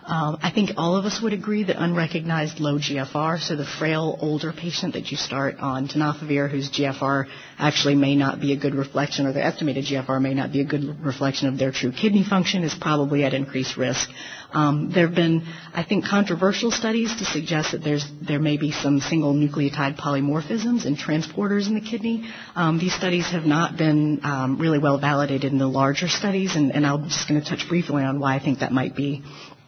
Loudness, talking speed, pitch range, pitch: -23 LUFS, 210 wpm, 140-170 Hz, 150 Hz